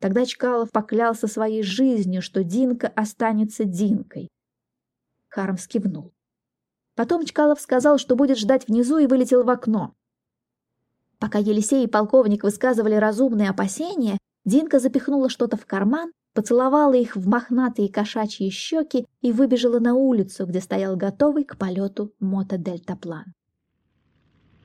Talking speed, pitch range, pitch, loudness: 120 wpm, 195-255 Hz, 220 Hz, -21 LUFS